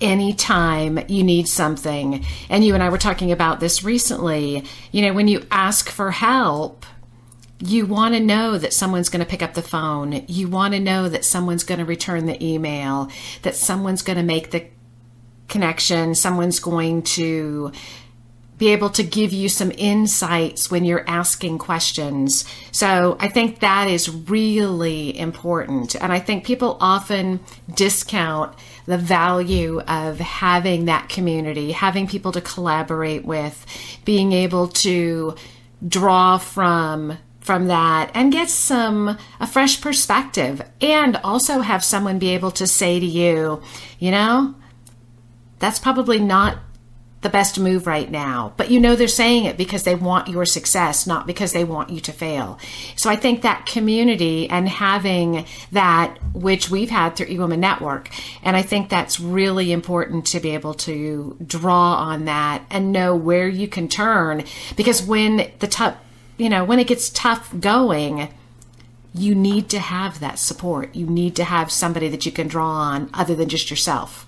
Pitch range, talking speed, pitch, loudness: 155-195 Hz, 165 wpm, 175 Hz, -19 LUFS